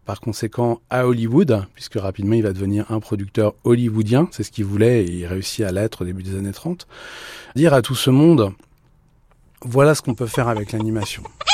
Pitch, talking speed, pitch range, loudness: 110 Hz, 200 wpm, 105-125 Hz, -19 LUFS